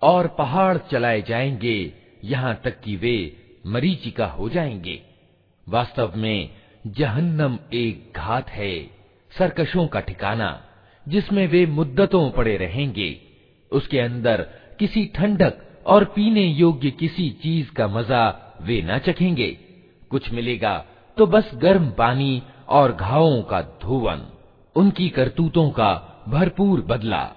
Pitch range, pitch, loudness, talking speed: 110-170 Hz, 130 Hz, -21 LUFS, 120 wpm